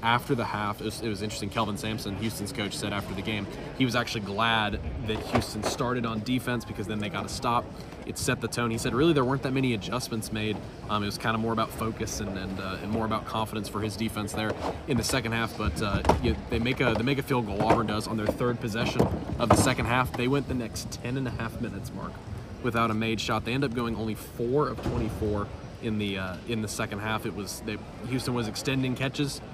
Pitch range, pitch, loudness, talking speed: 105-120 Hz, 110 Hz, -29 LUFS, 250 wpm